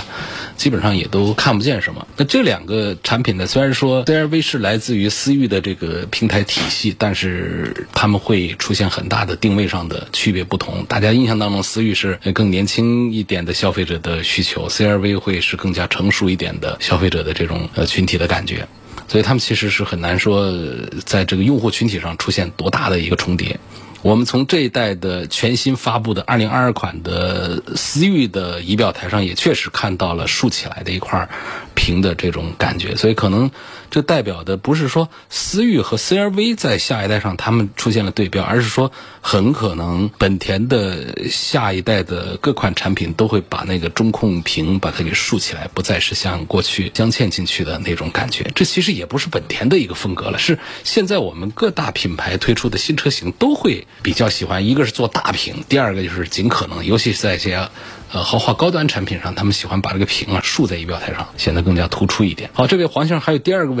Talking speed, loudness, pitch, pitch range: 320 characters per minute, -17 LUFS, 105 Hz, 90-120 Hz